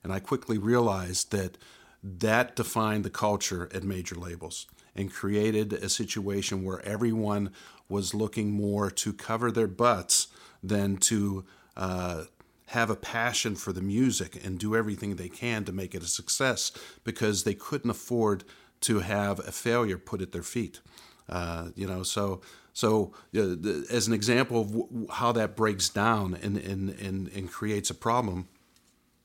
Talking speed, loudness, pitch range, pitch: 160 wpm, -29 LUFS, 95-110 Hz, 100 Hz